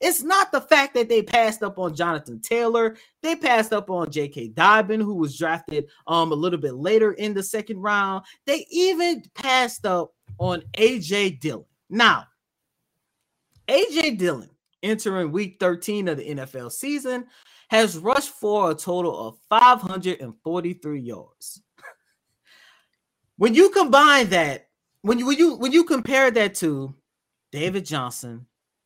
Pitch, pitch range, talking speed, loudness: 200 Hz, 160-245 Hz, 145 wpm, -21 LUFS